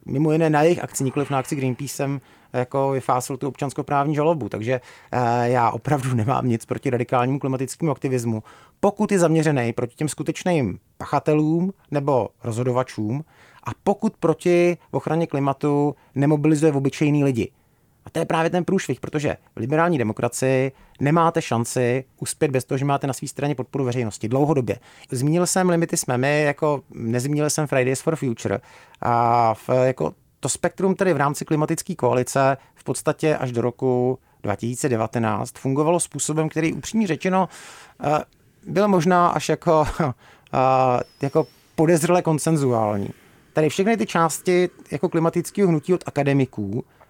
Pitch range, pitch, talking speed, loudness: 125-160 Hz, 140 Hz, 145 wpm, -22 LUFS